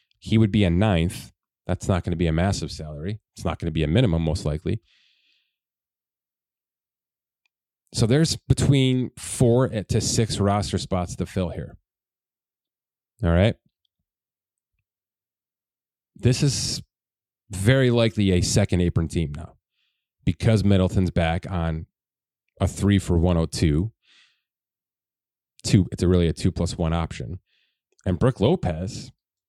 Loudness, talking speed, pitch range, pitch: -23 LUFS, 130 wpm, 85-110 Hz, 95 Hz